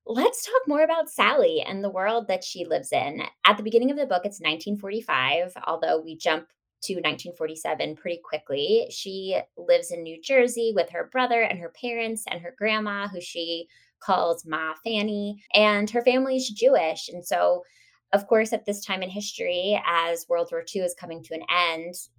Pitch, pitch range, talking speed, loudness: 200 Hz, 170-235 Hz, 185 wpm, -25 LUFS